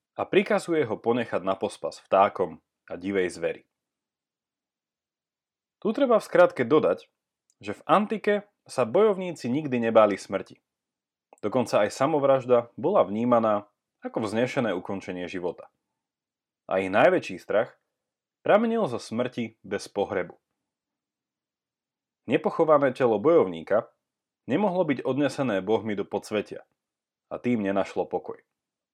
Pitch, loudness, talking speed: 120 Hz, -25 LUFS, 110 wpm